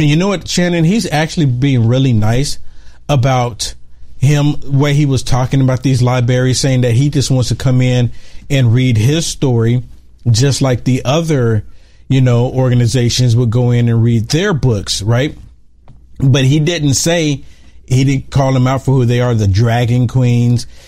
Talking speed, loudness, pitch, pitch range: 170 wpm, -13 LUFS, 130 Hz, 120-140 Hz